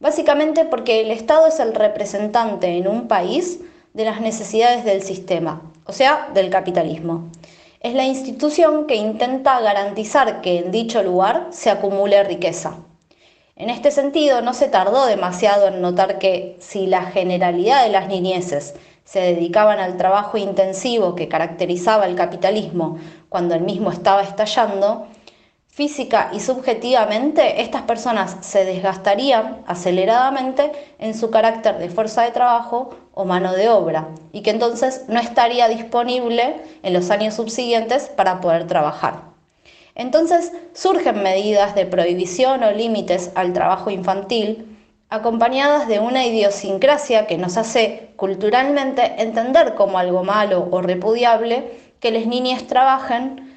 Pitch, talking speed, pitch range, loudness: 215 Hz, 135 wpm, 190-250 Hz, -18 LUFS